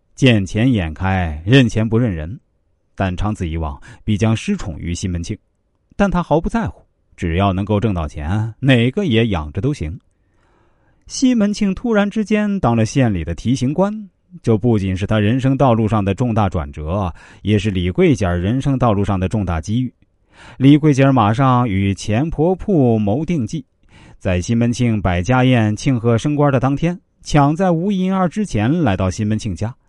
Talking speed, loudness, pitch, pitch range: 255 characters per minute, -17 LUFS, 110 Hz, 100-140 Hz